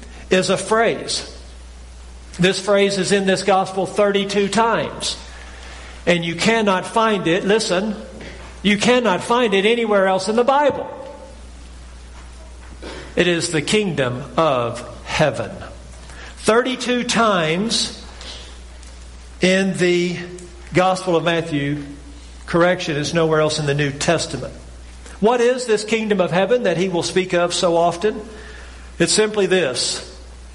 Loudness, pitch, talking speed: -18 LUFS, 175 Hz, 125 wpm